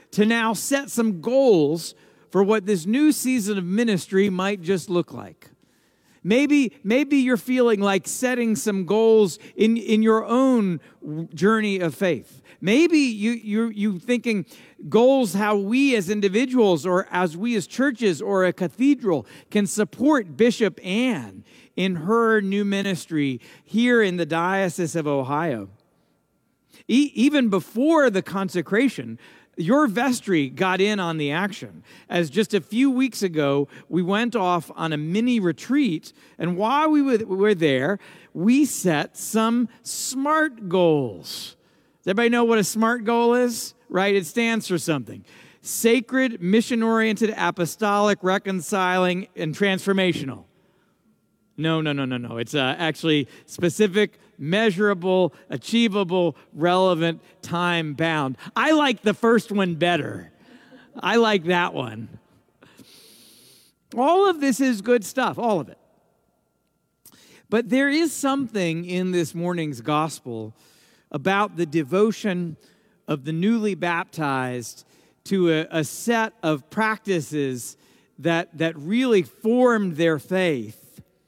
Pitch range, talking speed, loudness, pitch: 165-230 Hz, 130 wpm, -22 LUFS, 195 Hz